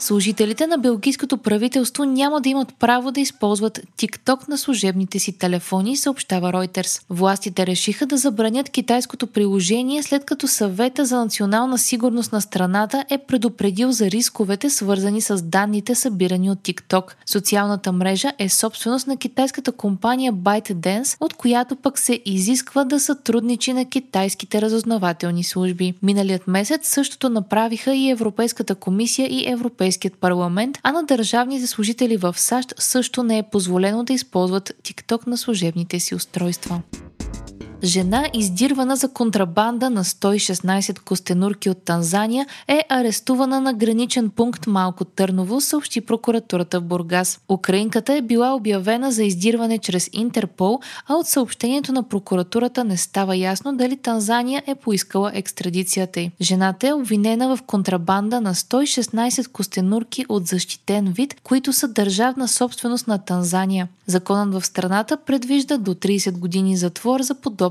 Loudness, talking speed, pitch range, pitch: -20 LUFS, 140 wpm, 190-255 Hz, 220 Hz